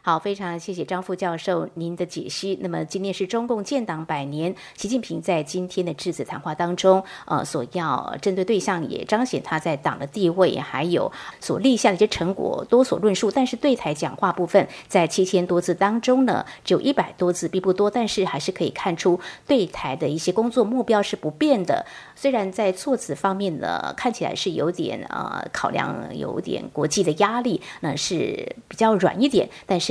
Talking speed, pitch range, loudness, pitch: 295 characters per minute, 175-220 Hz, -23 LUFS, 190 Hz